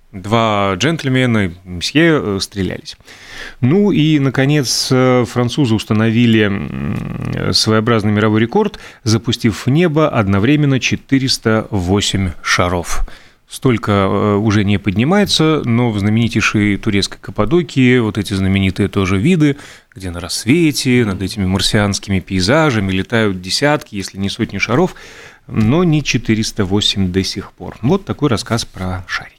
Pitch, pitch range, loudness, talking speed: 110 Hz, 100-130 Hz, -15 LUFS, 115 wpm